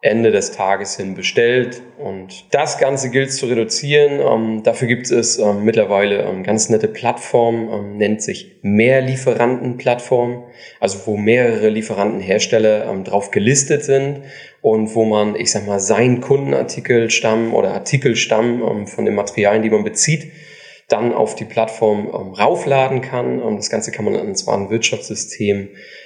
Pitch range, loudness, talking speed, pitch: 105-125 Hz, -16 LUFS, 155 wpm, 115 Hz